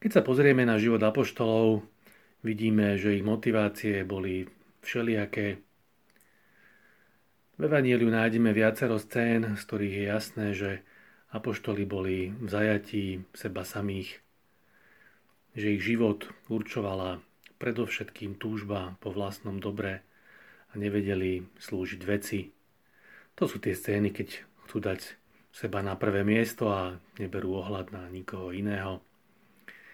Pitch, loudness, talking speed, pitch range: 105 Hz, -30 LUFS, 115 wpm, 95-110 Hz